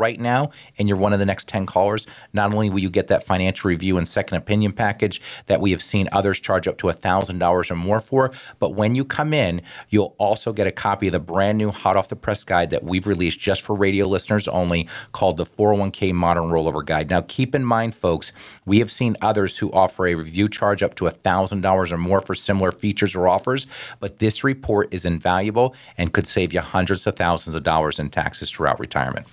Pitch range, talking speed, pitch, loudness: 90-105 Hz, 225 wpm, 100 Hz, -21 LUFS